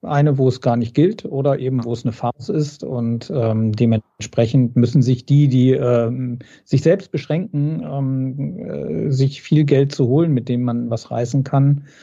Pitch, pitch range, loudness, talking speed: 130 Hz, 120-145 Hz, -18 LUFS, 185 wpm